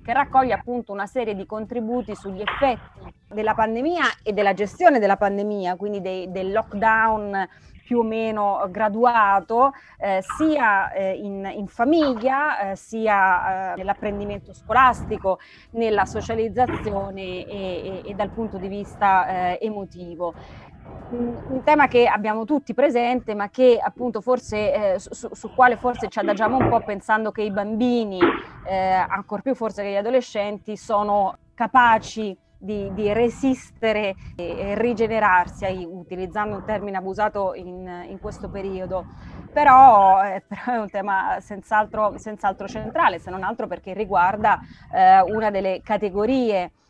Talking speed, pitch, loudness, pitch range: 145 wpm, 210 Hz, -21 LUFS, 195-235 Hz